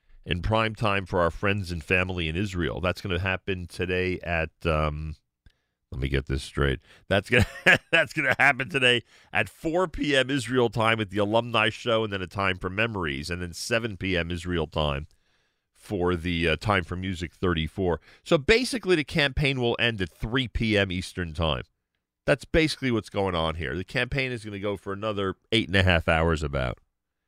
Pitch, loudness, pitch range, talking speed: 95 Hz, -26 LUFS, 85-115 Hz, 195 wpm